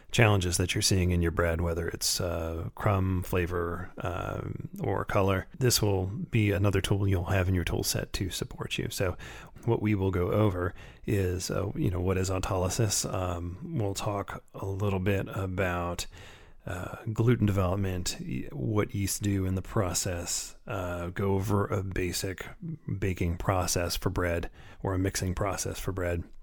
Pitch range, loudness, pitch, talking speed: 90-105 Hz, -30 LUFS, 95 Hz, 165 wpm